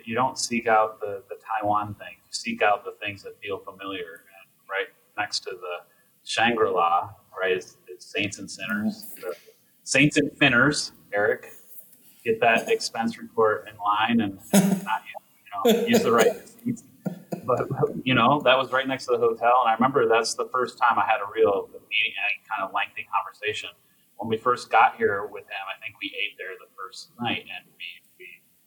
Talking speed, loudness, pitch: 195 wpm, -24 LUFS, 235 Hz